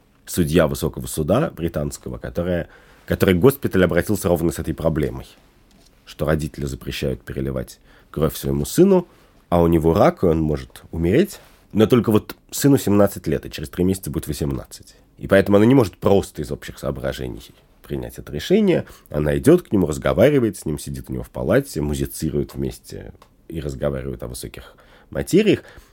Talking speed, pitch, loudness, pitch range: 160 wpm, 80 Hz, -20 LUFS, 70-95 Hz